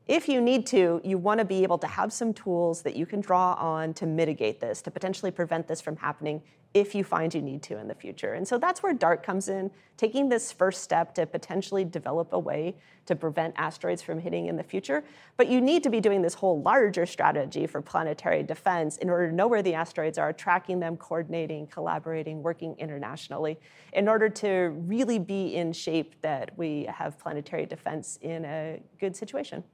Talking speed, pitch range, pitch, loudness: 210 wpm, 160-195 Hz, 175 Hz, -28 LUFS